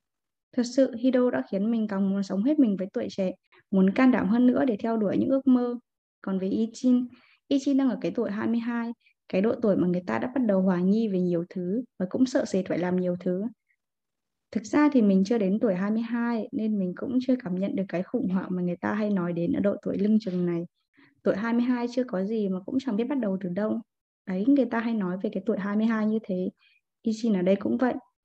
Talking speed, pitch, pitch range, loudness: 245 wpm, 220 Hz, 190-245 Hz, -26 LUFS